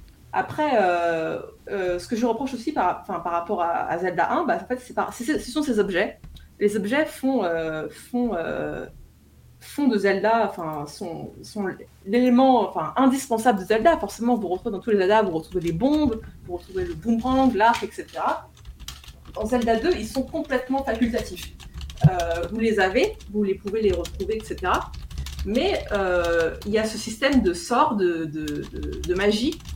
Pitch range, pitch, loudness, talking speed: 170-245 Hz, 210 Hz, -24 LUFS, 180 wpm